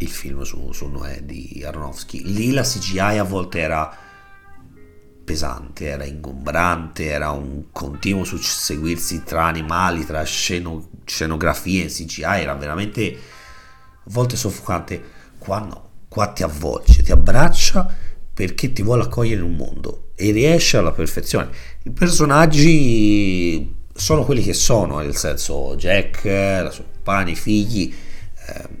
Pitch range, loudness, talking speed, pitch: 75-100 Hz, -19 LUFS, 135 wpm, 85 Hz